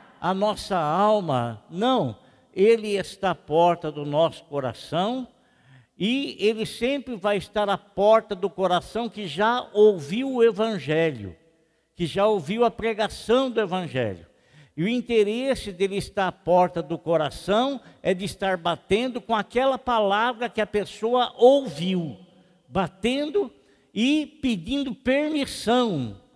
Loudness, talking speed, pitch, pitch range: -24 LUFS, 125 wpm, 205 Hz, 170-235 Hz